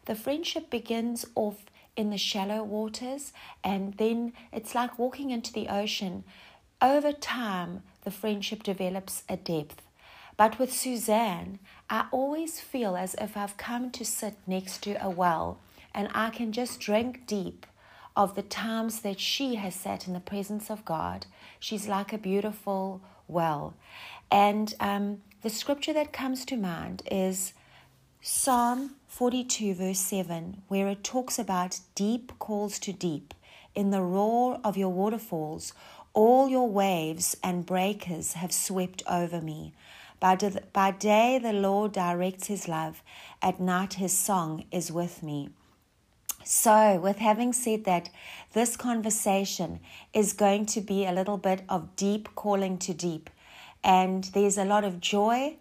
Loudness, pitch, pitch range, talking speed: -29 LUFS, 205 Hz, 185-225 Hz, 150 wpm